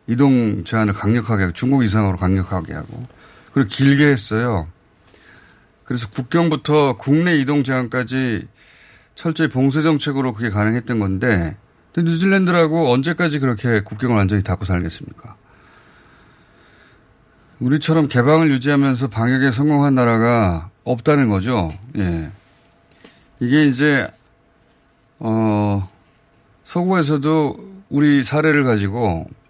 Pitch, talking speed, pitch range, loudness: 125 Hz, 275 characters per minute, 105-145 Hz, -18 LUFS